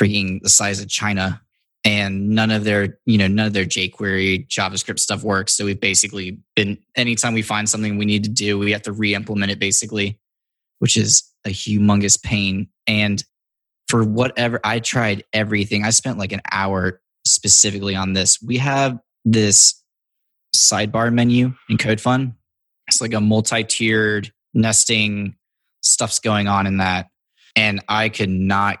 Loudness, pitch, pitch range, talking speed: -17 LUFS, 105 Hz, 100-110 Hz, 160 wpm